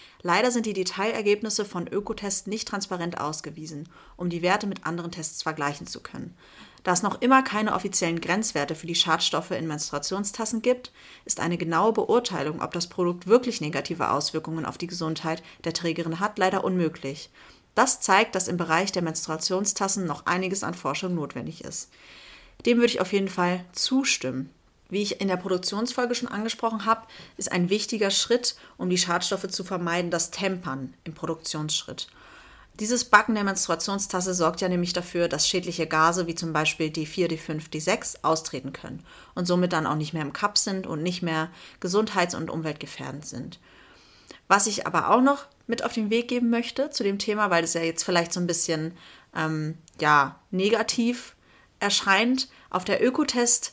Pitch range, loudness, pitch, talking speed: 160-210 Hz, -25 LUFS, 180 Hz, 175 wpm